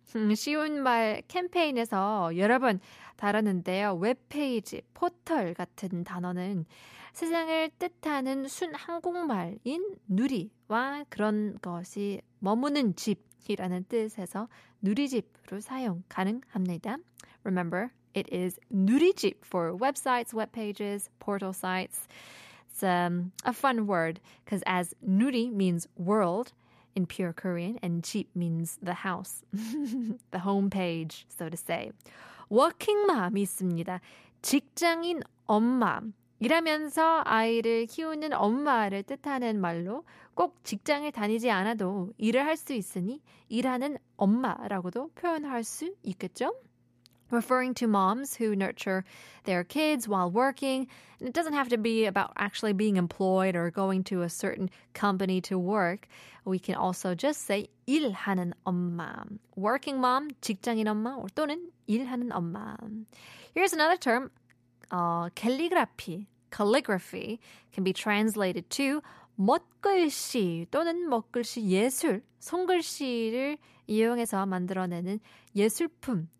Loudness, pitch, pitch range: -30 LUFS, 215 Hz, 185-265 Hz